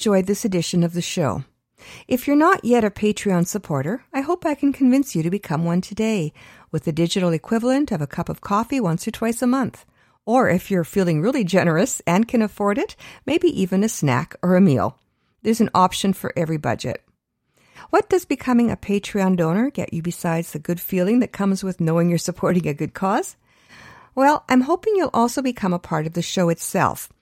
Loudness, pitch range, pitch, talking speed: -21 LUFS, 170-245 Hz, 195 Hz, 205 wpm